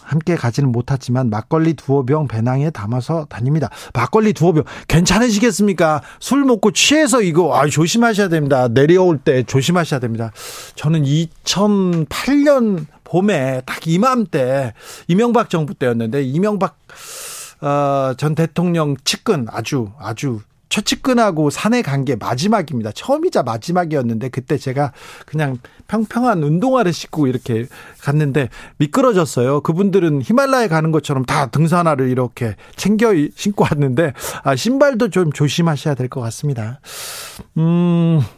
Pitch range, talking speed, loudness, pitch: 135-195 Hz, 310 characters per minute, -16 LUFS, 155 Hz